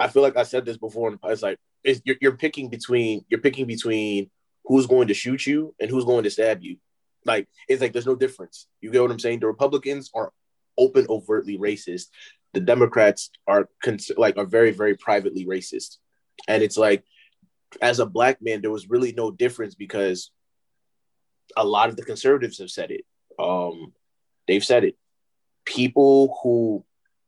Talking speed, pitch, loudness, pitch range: 185 wpm, 120 Hz, -22 LUFS, 110-140 Hz